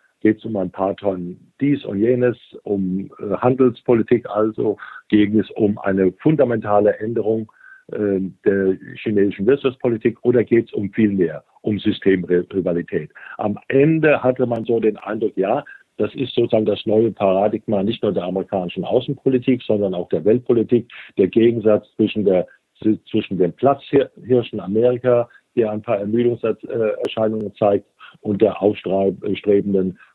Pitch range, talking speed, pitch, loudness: 100-120 Hz, 140 wpm, 105 Hz, -19 LUFS